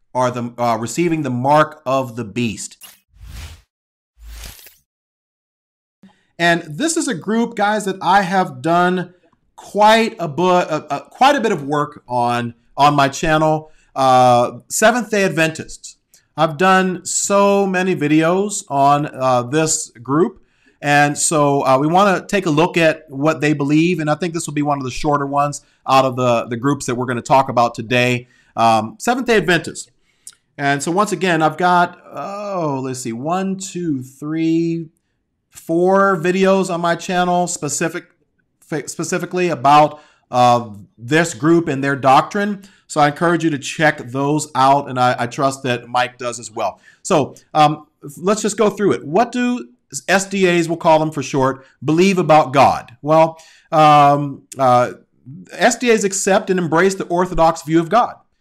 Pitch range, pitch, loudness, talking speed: 130-180 Hz, 155 Hz, -16 LUFS, 160 wpm